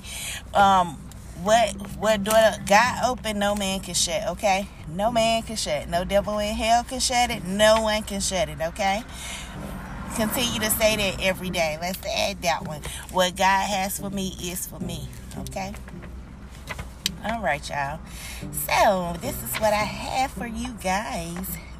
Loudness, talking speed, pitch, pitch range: -24 LUFS, 160 wpm, 200 Hz, 180-220 Hz